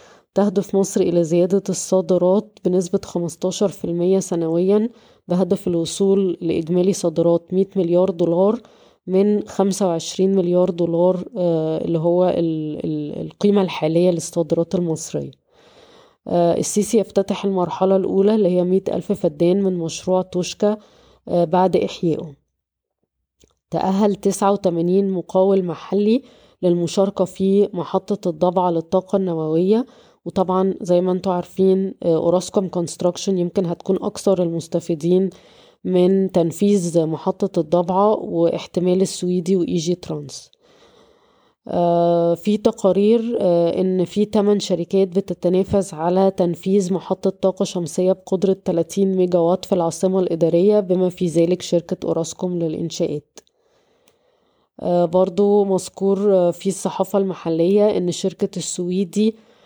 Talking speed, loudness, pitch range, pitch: 100 wpm, -19 LUFS, 175-195 Hz, 185 Hz